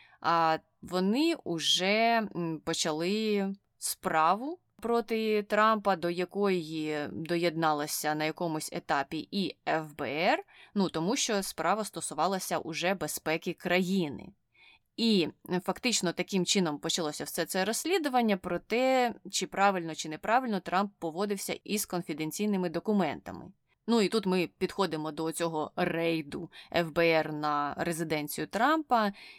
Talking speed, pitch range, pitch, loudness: 110 wpm, 160-205 Hz, 180 Hz, -30 LUFS